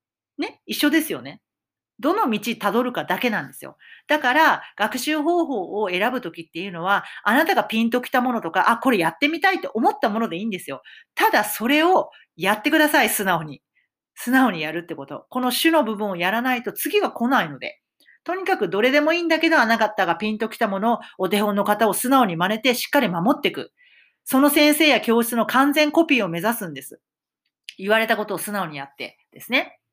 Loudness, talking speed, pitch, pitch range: -20 LUFS, 400 characters per minute, 245 Hz, 210-300 Hz